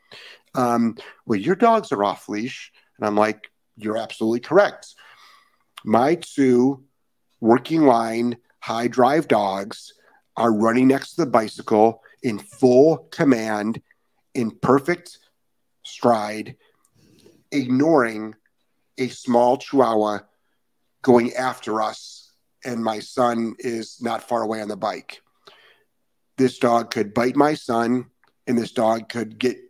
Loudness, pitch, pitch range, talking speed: -21 LUFS, 120 Hz, 110-135 Hz, 120 wpm